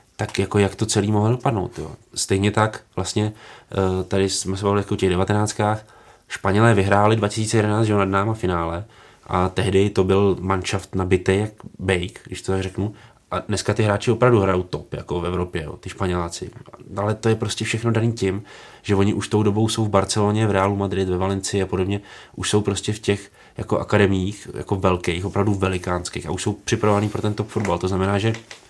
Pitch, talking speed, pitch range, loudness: 100 Hz, 200 wpm, 95-105 Hz, -21 LUFS